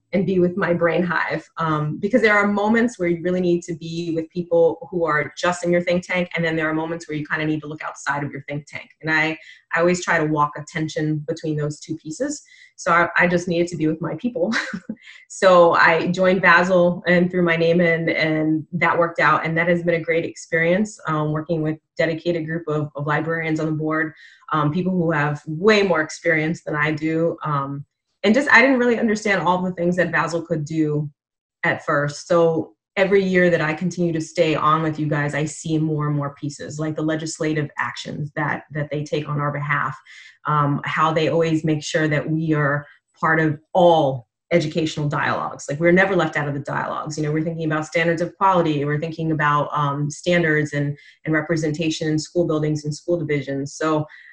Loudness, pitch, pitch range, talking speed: -20 LUFS, 160 Hz, 150-175 Hz, 220 wpm